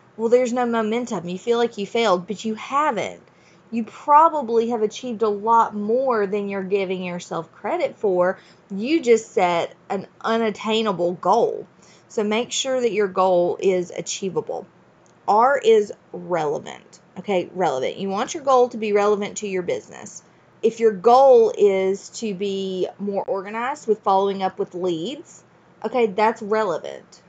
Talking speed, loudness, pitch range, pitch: 155 wpm, -21 LUFS, 195-235 Hz, 215 Hz